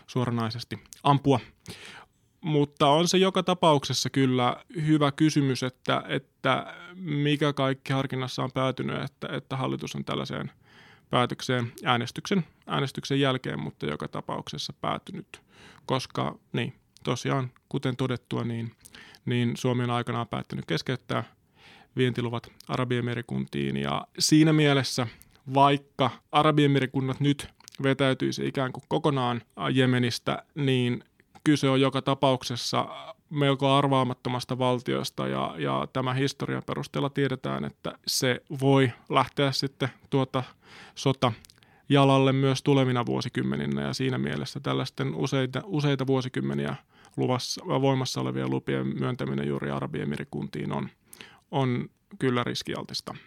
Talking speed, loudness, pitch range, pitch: 110 wpm, -27 LUFS, 105-140 Hz, 130 Hz